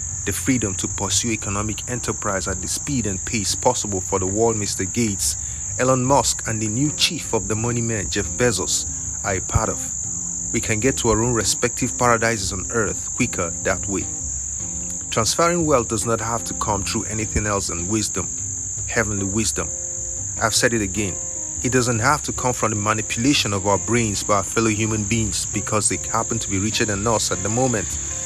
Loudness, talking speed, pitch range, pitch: -21 LUFS, 195 wpm, 95-115 Hz, 105 Hz